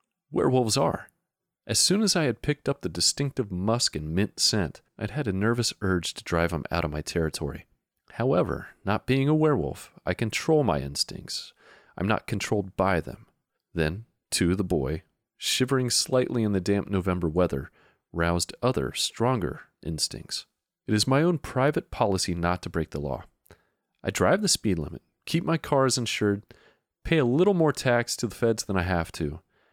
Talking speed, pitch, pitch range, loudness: 180 wpm, 105 Hz, 90-130 Hz, -26 LUFS